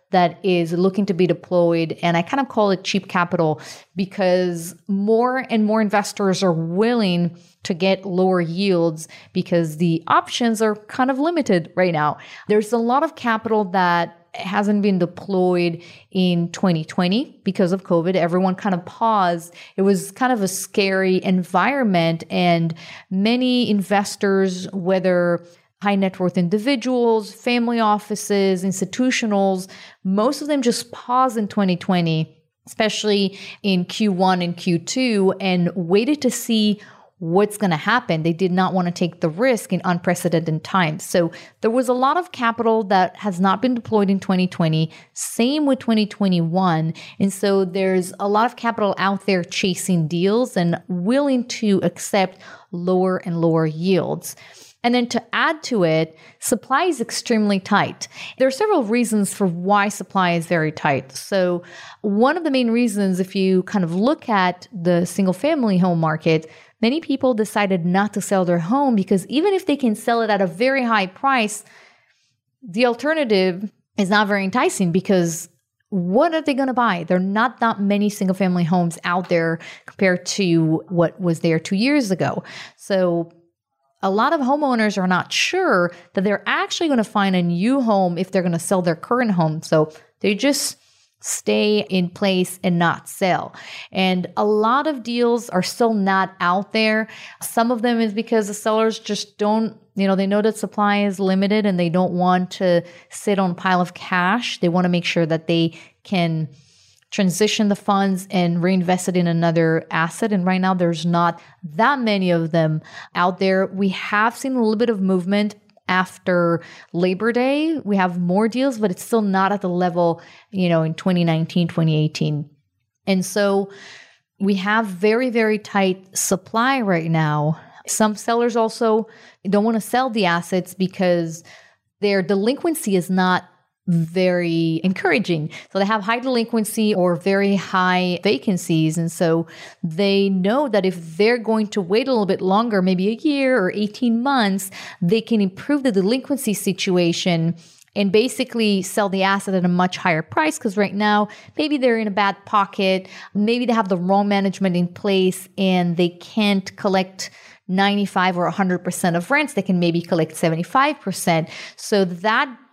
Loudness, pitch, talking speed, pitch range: -20 LUFS, 195 Hz, 170 wpm, 175-220 Hz